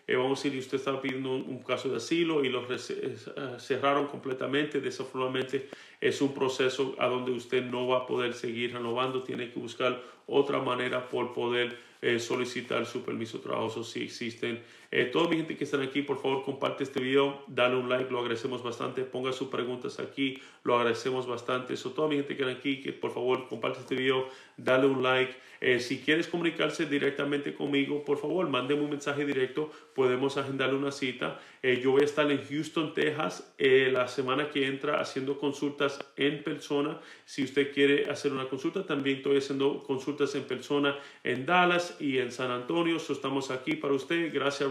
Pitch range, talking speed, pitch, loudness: 130-145 Hz, 195 wpm, 135 Hz, -30 LUFS